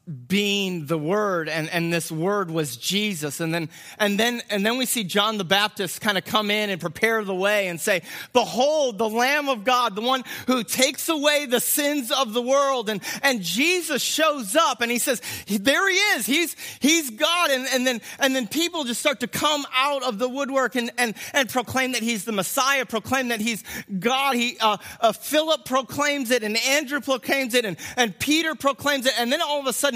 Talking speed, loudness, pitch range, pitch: 210 wpm, -22 LUFS, 210-275 Hz, 245 Hz